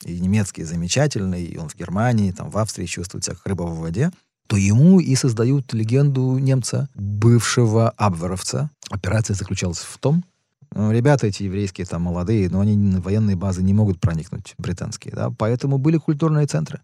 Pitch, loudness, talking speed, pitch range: 110 Hz, -20 LUFS, 170 wpm, 95-135 Hz